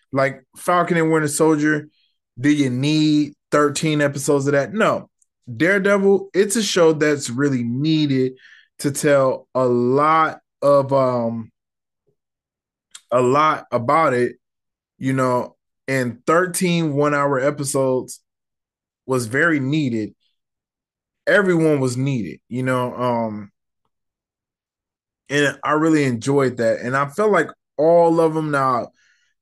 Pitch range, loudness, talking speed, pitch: 125-155 Hz, -19 LUFS, 120 wpm, 140 Hz